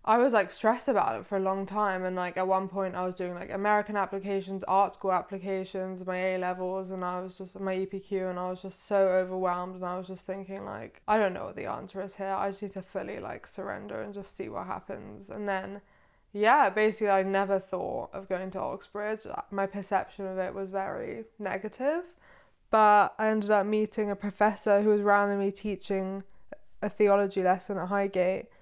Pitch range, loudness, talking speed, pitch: 190-205 Hz, -29 LUFS, 210 wpm, 195 Hz